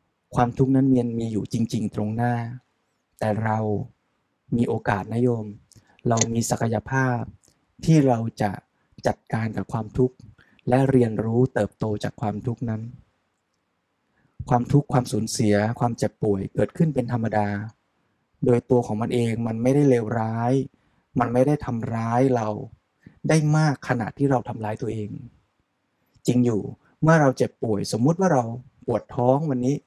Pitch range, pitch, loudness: 110-130 Hz, 120 Hz, -23 LUFS